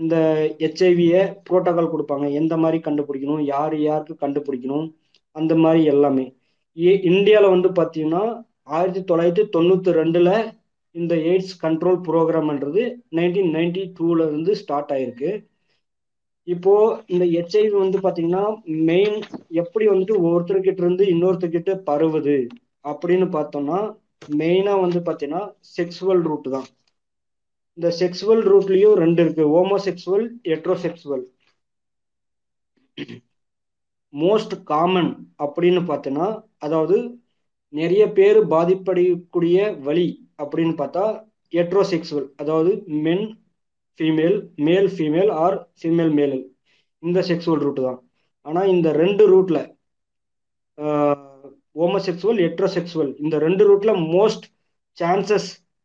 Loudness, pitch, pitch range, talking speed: -19 LUFS, 170 Hz, 150-190 Hz, 105 wpm